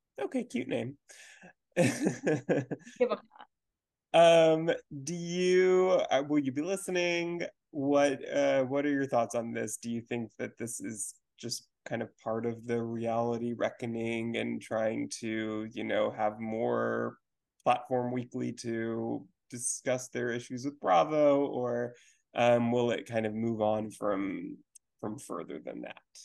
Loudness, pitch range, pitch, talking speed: -31 LUFS, 115-145 Hz, 120 Hz, 135 wpm